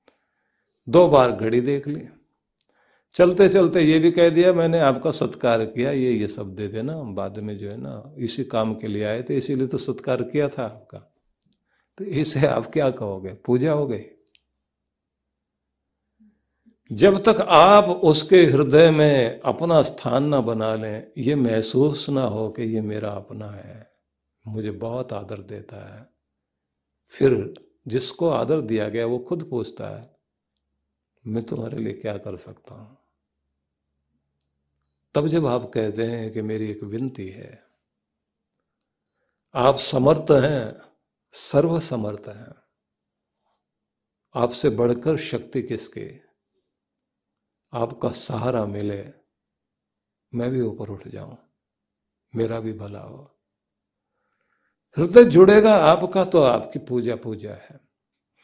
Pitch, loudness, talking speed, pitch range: 115 Hz, -20 LUFS, 130 wpm, 100-140 Hz